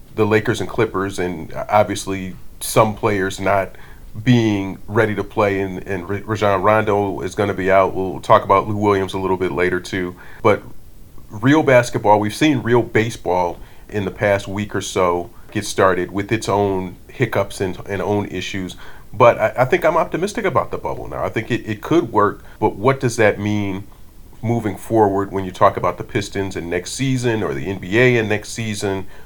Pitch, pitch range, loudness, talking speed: 100 Hz, 95-110 Hz, -19 LUFS, 190 wpm